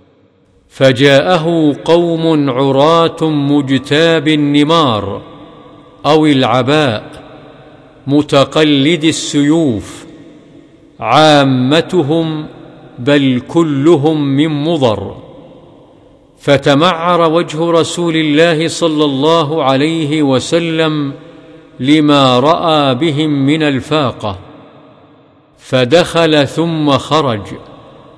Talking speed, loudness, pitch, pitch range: 65 wpm, -11 LUFS, 155 Hz, 140-160 Hz